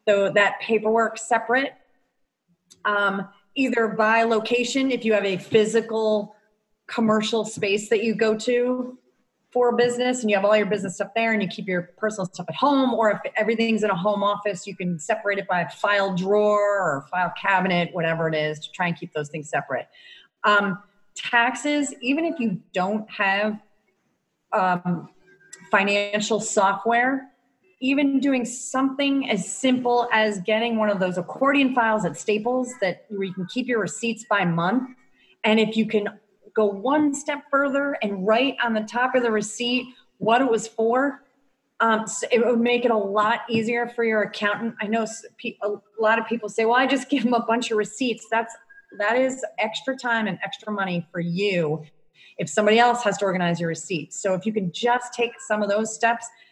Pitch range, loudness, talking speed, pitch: 200-240 Hz, -23 LUFS, 185 wpm, 220 Hz